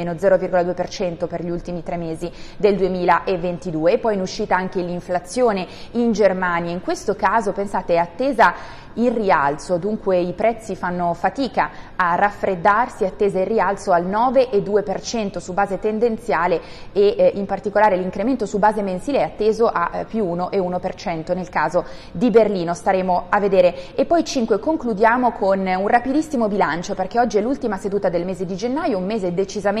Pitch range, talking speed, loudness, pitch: 180-220 Hz, 165 wpm, -20 LUFS, 195 Hz